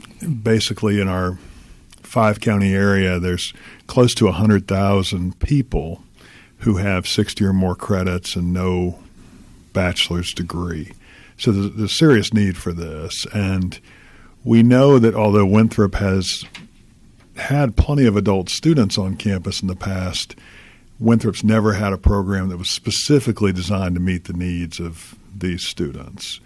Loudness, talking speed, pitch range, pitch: -18 LUFS, 140 wpm, 90-110 Hz, 100 Hz